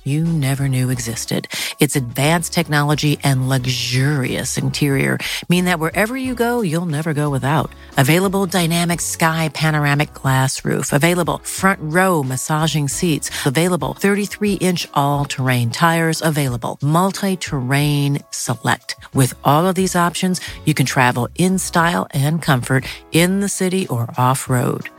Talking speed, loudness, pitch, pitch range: 140 wpm, -18 LUFS, 155 Hz, 135-175 Hz